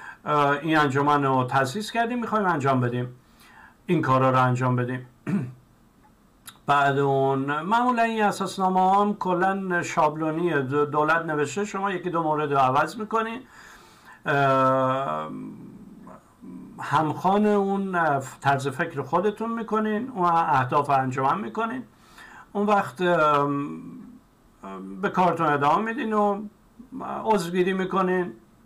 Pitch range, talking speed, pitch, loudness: 135-200 Hz, 105 wpm, 160 Hz, -24 LUFS